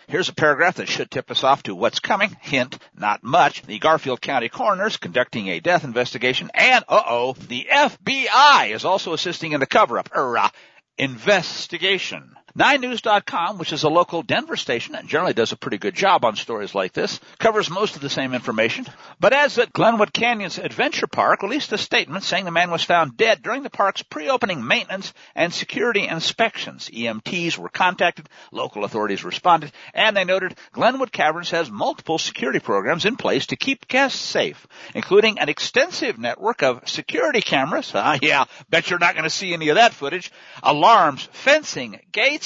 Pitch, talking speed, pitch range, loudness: 175 Hz, 180 wpm, 155-225 Hz, -20 LUFS